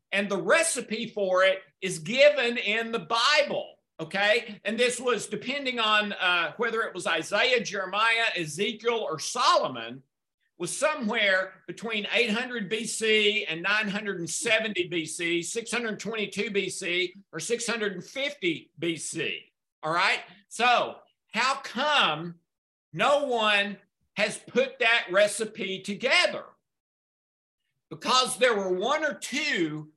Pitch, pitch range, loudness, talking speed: 210 Hz, 185-235 Hz, -26 LUFS, 110 wpm